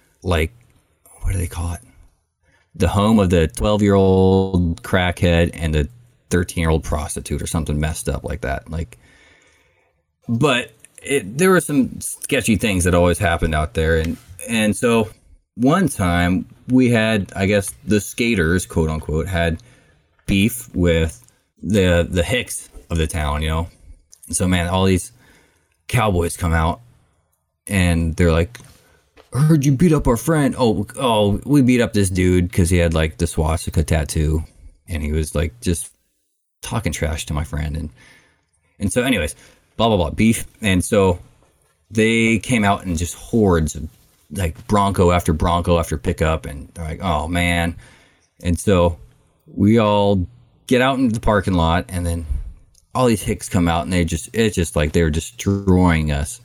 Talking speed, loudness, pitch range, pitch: 165 wpm, -19 LUFS, 80-105 Hz, 90 Hz